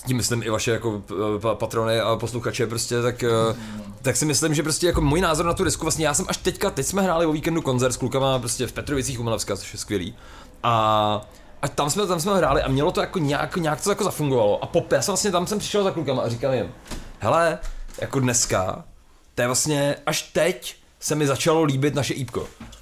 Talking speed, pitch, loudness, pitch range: 220 wpm, 135 Hz, -23 LUFS, 115-160 Hz